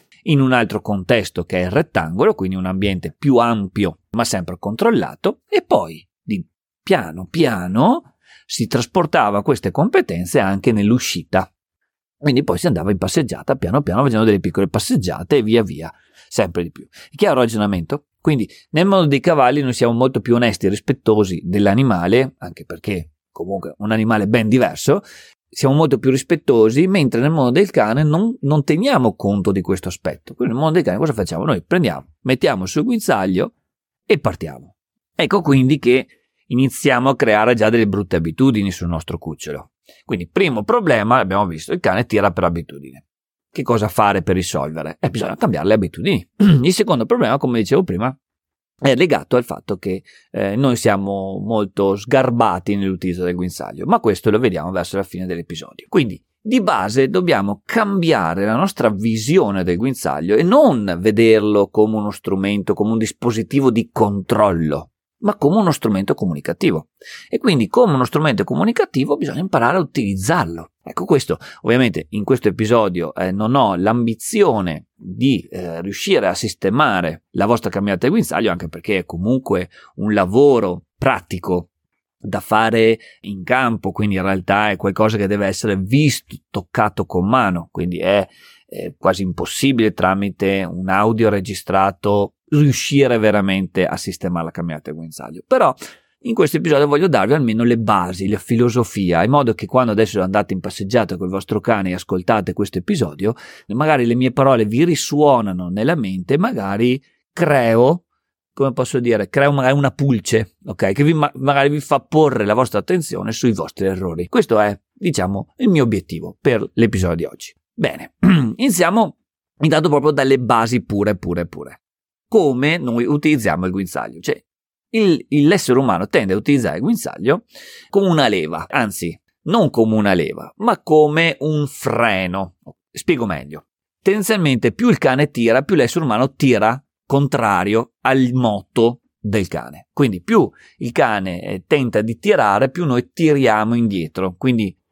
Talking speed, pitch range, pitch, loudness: 160 wpm, 95-135 Hz, 110 Hz, -17 LUFS